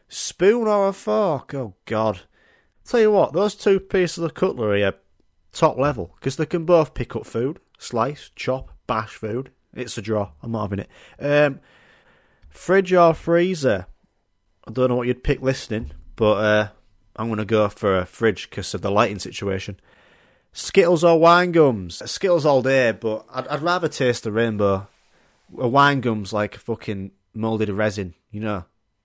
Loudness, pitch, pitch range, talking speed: -21 LUFS, 120 Hz, 105-160 Hz, 175 wpm